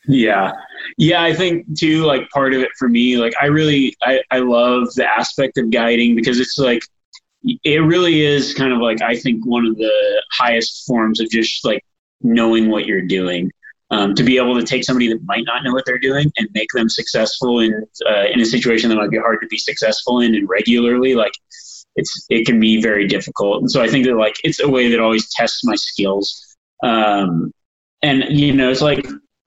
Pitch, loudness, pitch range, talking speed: 120 Hz, -15 LUFS, 115-140 Hz, 210 wpm